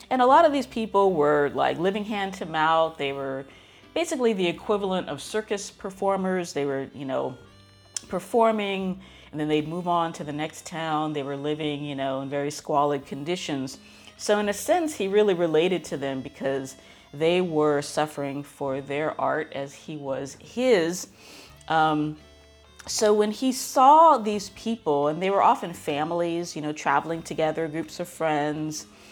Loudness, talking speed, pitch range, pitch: -25 LUFS, 170 wpm, 145-195 Hz, 160 Hz